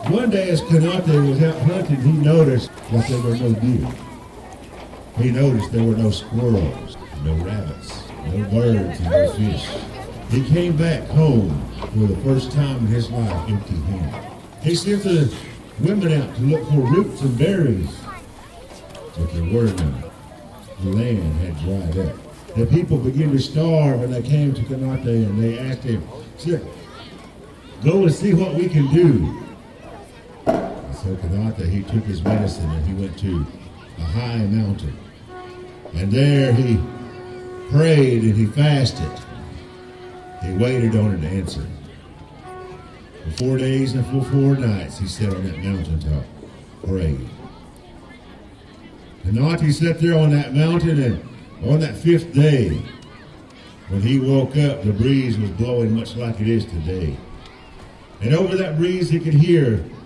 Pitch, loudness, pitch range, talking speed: 120 Hz, -19 LUFS, 95-140 Hz, 150 wpm